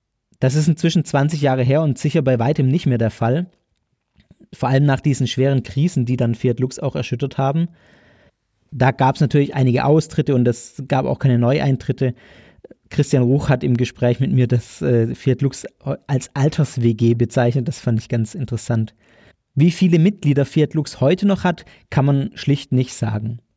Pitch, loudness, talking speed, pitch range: 130 Hz, -18 LUFS, 180 wpm, 120-145 Hz